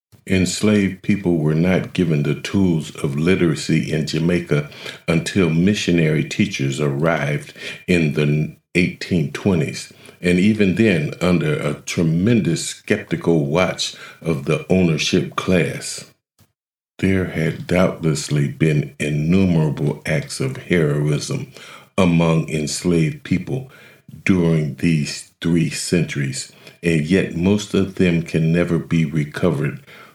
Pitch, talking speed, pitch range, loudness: 85 Hz, 105 wpm, 75-90 Hz, -19 LUFS